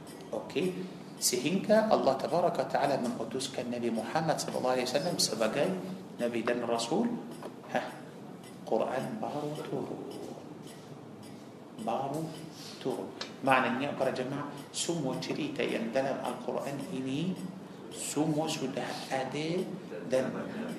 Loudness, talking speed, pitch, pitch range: -32 LUFS, 105 wpm, 130 Hz, 120-155 Hz